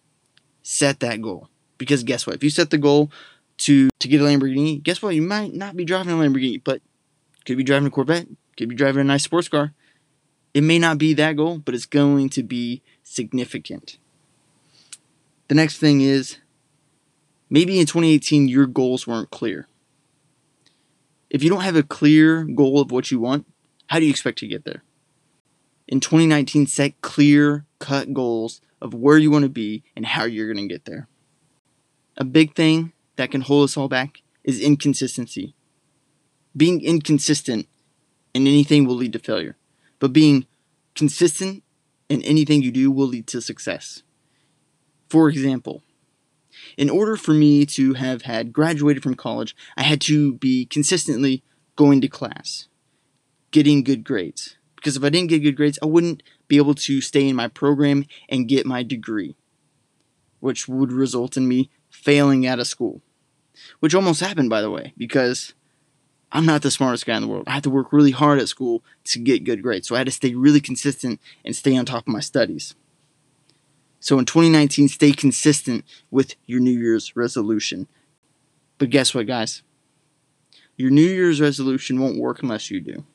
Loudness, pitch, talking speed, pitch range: -19 LUFS, 145 Hz, 175 wpm, 135-150 Hz